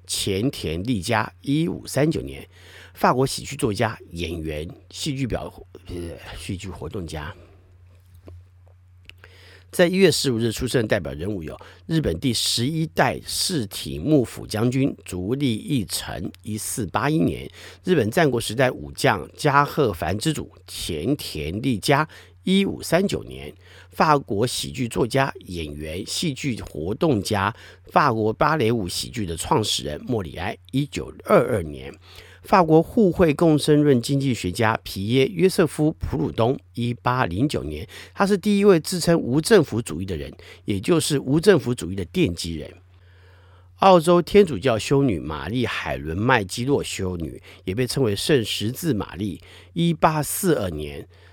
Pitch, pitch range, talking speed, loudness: 105 Hz, 90-140 Hz, 230 characters per minute, -22 LUFS